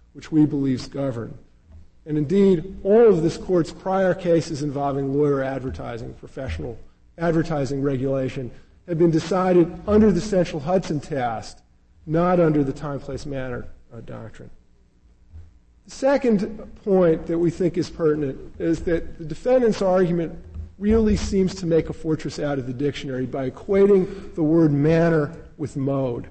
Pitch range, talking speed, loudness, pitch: 135-180 Hz, 145 wpm, -22 LUFS, 155 Hz